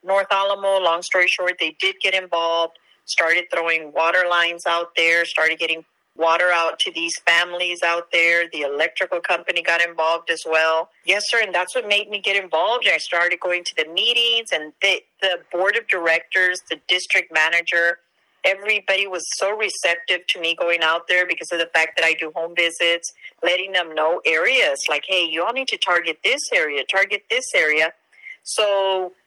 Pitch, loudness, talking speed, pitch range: 175 Hz, -19 LUFS, 185 wpm, 165-195 Hz